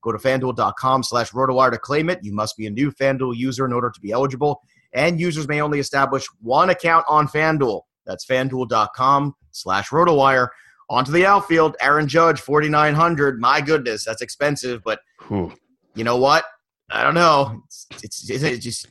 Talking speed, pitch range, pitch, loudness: 175 wpm, 130-150 Hz, 140 Hz, -19 LUFS